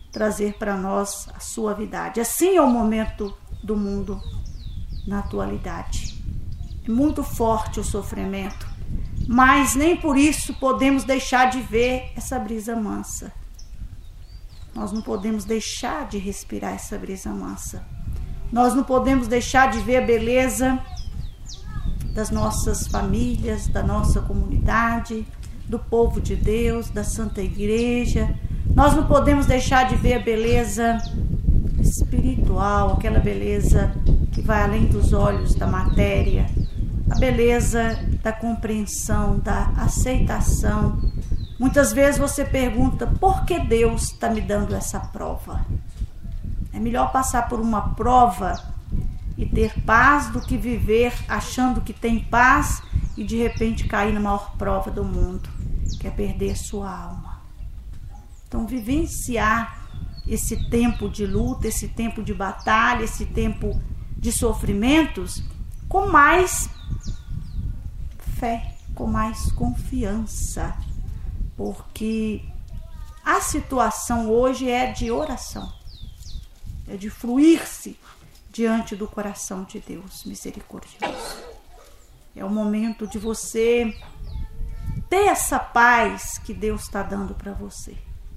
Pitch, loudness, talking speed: 205 Hz, -22 LUFS, 120 wpm